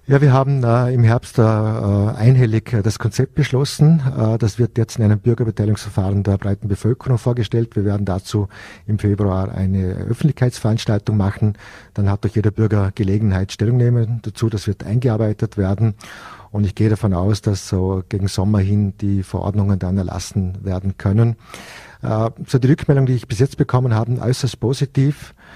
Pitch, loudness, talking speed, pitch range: 110 Hz, -18 LUFS, 170 wpm, 100-120 Hz